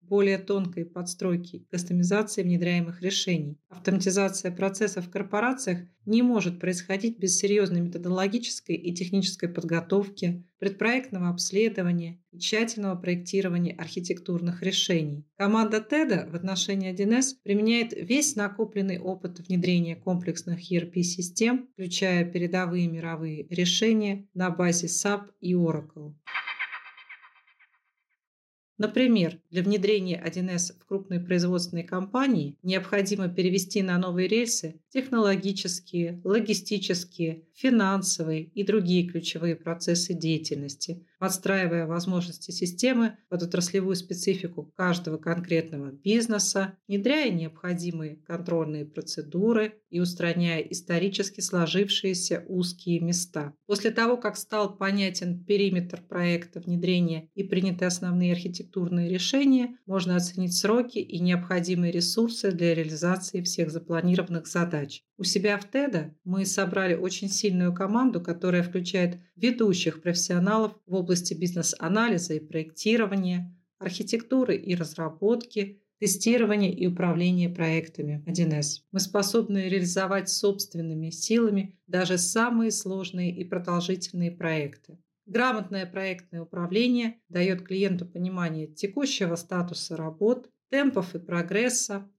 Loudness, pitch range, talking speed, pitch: -27 LUFS, 175-200 Hz, 105 wpm, 185 Hz